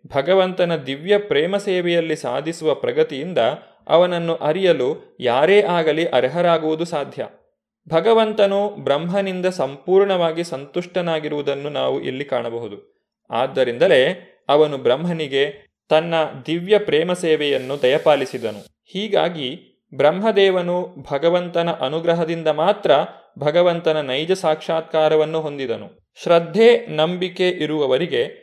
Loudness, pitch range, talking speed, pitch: -19 LUFS, 155-190 Hz, 80 wpm, 170 Hz